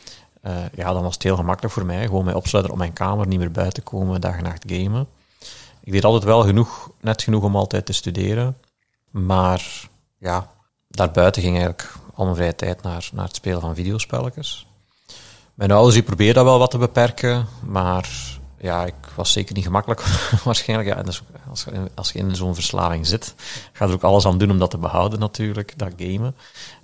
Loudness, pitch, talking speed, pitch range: -20 LUFS, 95 Hz, 195 wpm, 90-110 Hz